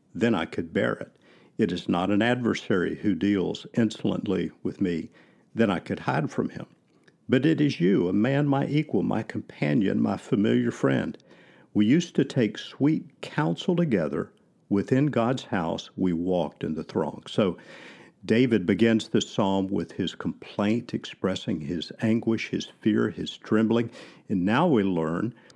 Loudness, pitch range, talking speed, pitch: -26 LUFS, 100-130 Hz, 160 wpm, 110 Hz